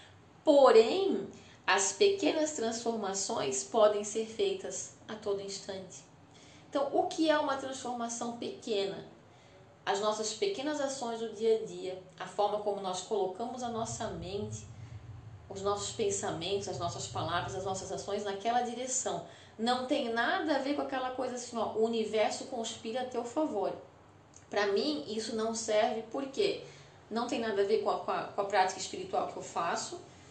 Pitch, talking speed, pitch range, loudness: 220 Hz, 160 wpm, 195-250 Hz, -33 LUFS